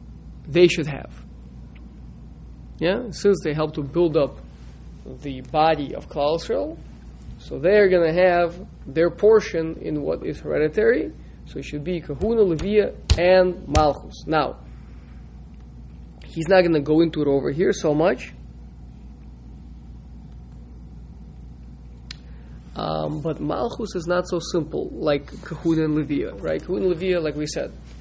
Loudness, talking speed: -22 LUFS, 135 wpm